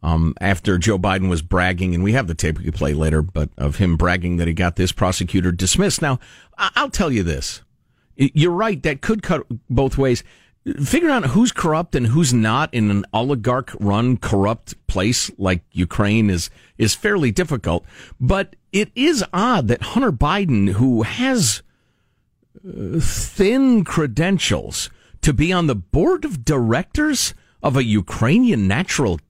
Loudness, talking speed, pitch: -19 LUFS, 160 wpm, 115 Hz